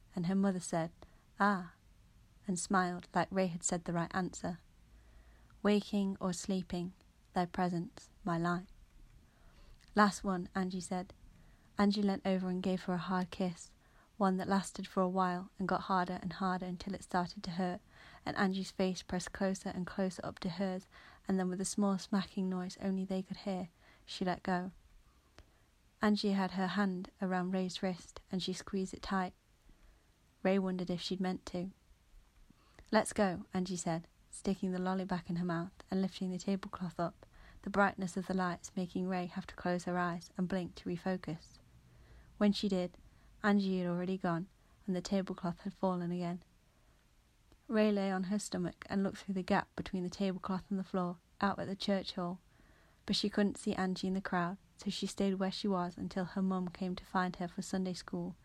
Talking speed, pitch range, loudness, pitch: 185 wpm, 180-195 Hz, -37 LUFS, 185 Hz